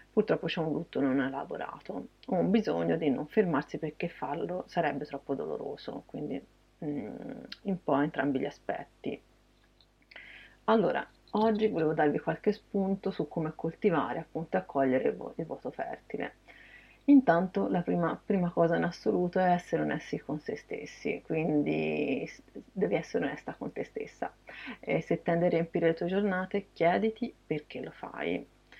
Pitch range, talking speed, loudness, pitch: 150-195 Hz, 150 wpm, -31 LUFS, 170 Hz